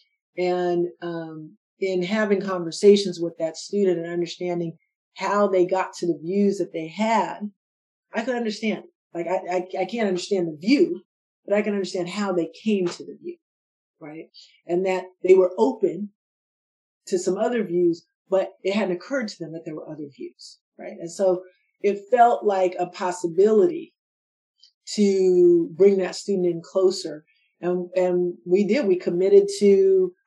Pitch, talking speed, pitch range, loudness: 185 Hz, 165 wpm, 175-210 Hz, -22 LUFS